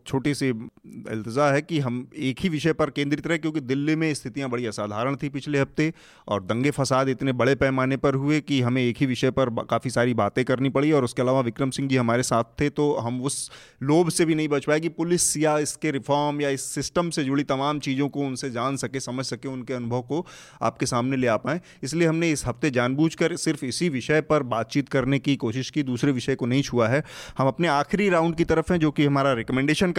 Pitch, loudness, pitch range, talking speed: 140 Hz, -24 LUFS, 130-150 Hz, 230 wpm